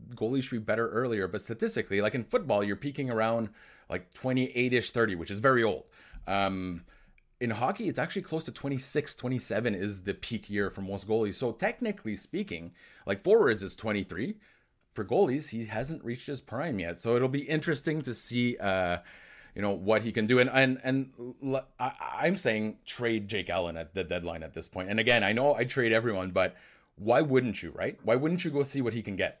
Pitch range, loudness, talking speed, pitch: 100-130 Hz, -30 LUFS, 205 wpm, 115 Hz